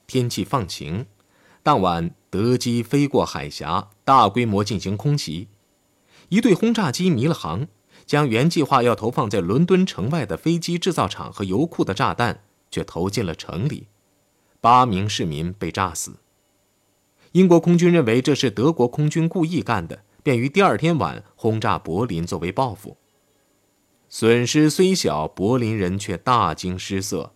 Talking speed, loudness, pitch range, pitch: 235 characters per minute, -20 LUFS, 95-155 Hz, 120 Hz